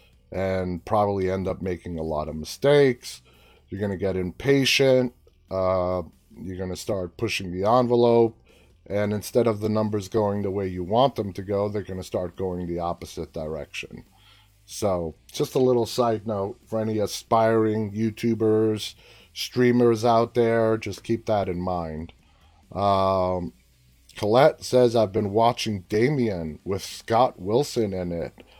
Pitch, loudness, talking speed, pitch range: 100 Hz, -24 LUFS, 155 wpm, 90-115 Hz